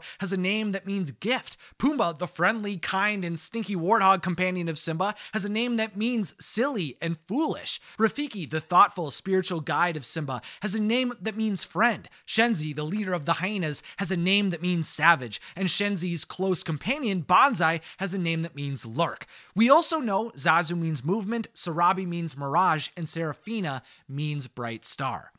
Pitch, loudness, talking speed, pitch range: 185 Hz, -26 LUFS, 175 wpm, 165-210 Hz